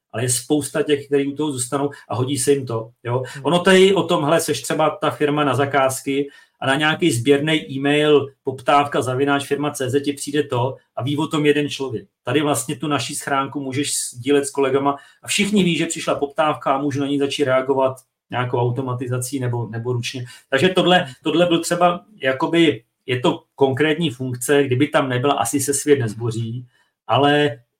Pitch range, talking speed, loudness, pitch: 130-150 Hz, 185 wpm, -19 LUFS, 140 Hz